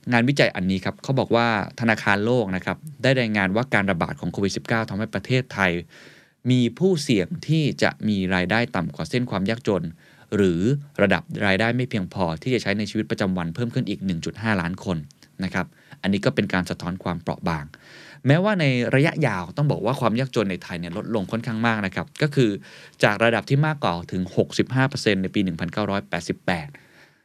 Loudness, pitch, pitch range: -23 LUFS, 110 Hz, 95-125 Hz